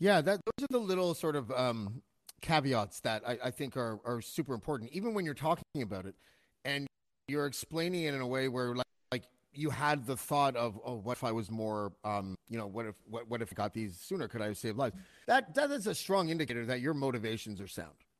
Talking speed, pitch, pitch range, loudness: 235 wpm, 125 Hz, 115-155 Hz, -35 LUFS